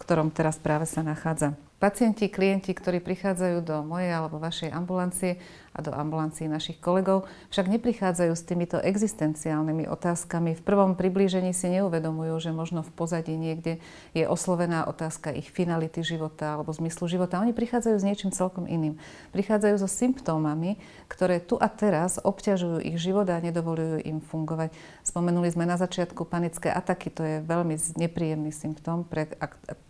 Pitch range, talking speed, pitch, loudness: 160-185 Hz, 155 wpm, 170 Hz, -28 LUFS